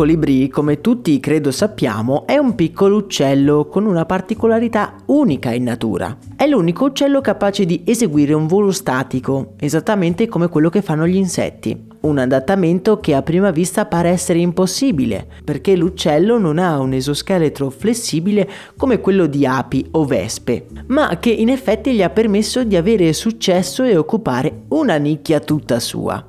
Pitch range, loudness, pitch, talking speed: 145-210 Hz, -16 LUFS, 175 Hz, 160 wpm